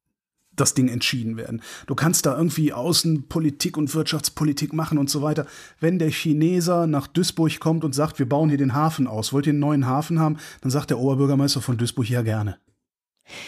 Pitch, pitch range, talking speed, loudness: 150 Hz, 135-160 Hz, 190 wpm, -22 LUFS